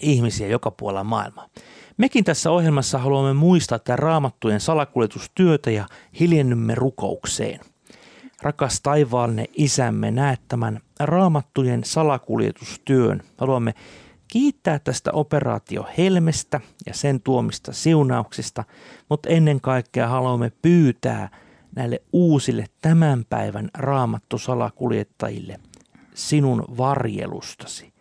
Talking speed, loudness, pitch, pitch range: 90 wpm, -21 LUFS, 130 Hz, 115-150 Hz